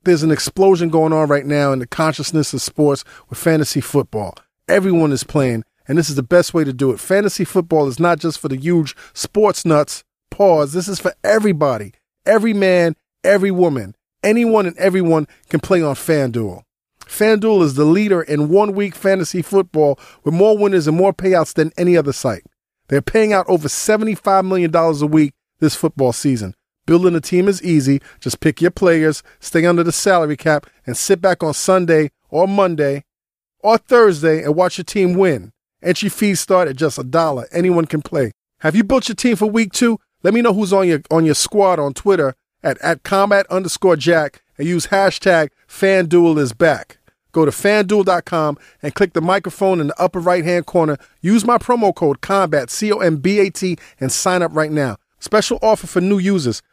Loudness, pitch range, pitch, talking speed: -16 LUFS, 150-195 Hz, 170 Hz, 195 wpm